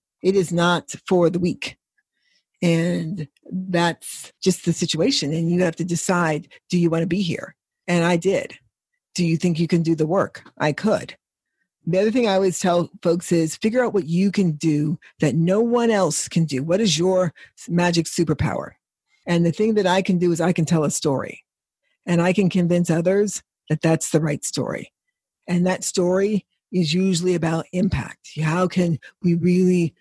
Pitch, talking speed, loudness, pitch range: 175 Hz, 190 wpm, -21 LUFS, 165-185 Hz